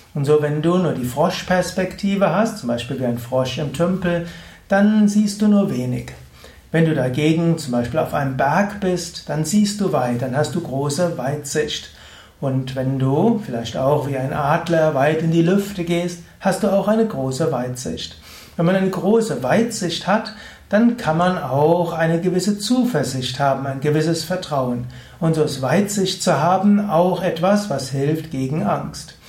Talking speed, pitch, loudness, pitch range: 175 wpm, 165 Hz, -19 LUFS, 135-190 Hz